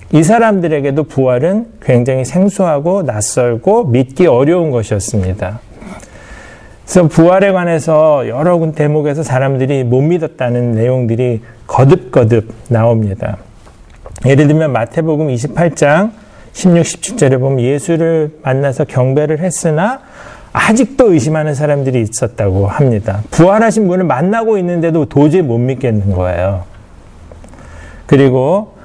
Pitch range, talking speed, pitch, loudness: 120-170 Hz, 285 characters per minute, 145 Hz, -12 LUFS